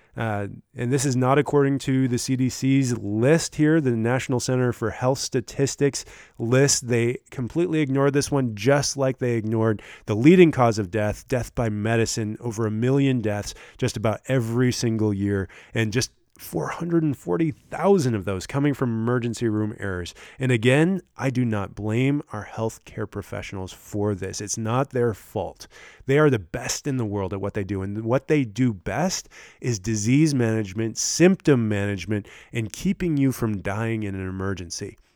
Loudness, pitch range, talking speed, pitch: -23 LUFS, 105-135 Hz, 165 wpm, 120 Hz